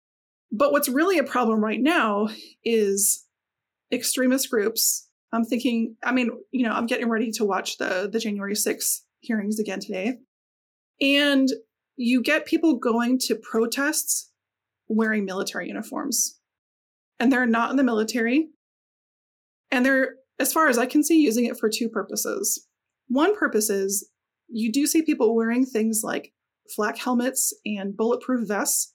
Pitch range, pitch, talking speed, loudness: 220-275 Hz, 240 Hz, 150 wpm, -23 LUFS